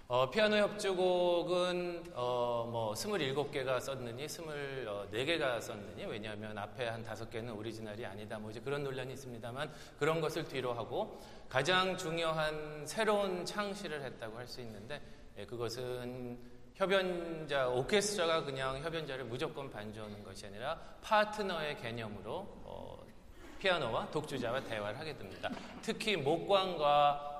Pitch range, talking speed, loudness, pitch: 120-175 Hz, 305 characters per minute, -36 LUFS, 140 Hz